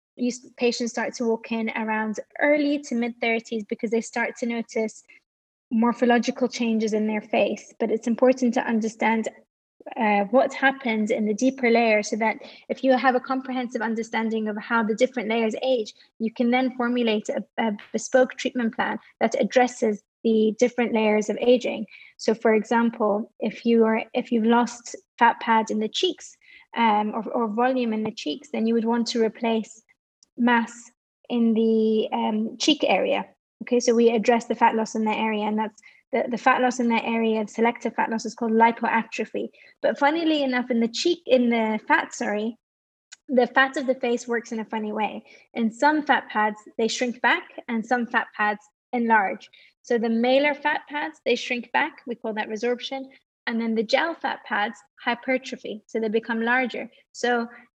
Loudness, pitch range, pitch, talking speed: -24 LUFS, 225-255 Hz, 235 Hz, 185 wpm